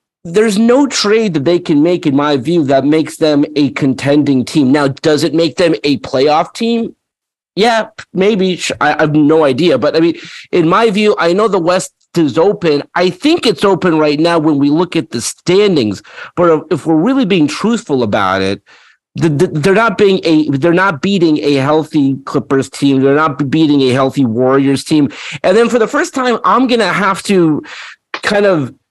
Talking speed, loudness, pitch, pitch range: 190 wpm, -12 LUFS, 165 Hz, 145-195 Hz